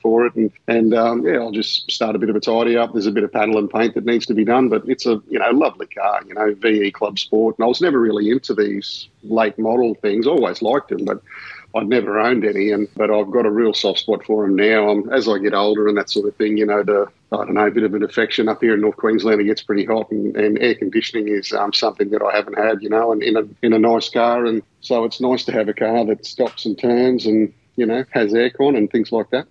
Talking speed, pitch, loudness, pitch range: 285 wpm, 110 Hz, -18 LUFS, 105-115 Hz